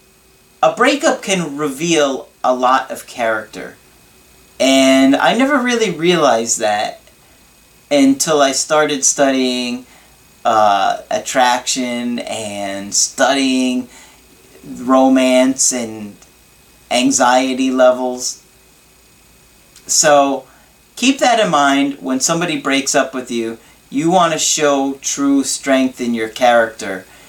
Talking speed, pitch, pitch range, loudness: 100 wpm, 135 Hz, 125-155 Hz, -14 LUFS